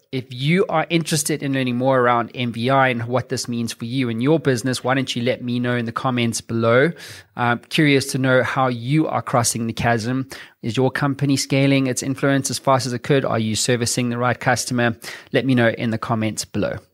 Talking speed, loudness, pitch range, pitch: 220 wpm, -20 LUFS, 120-135 Hz, 125 Hz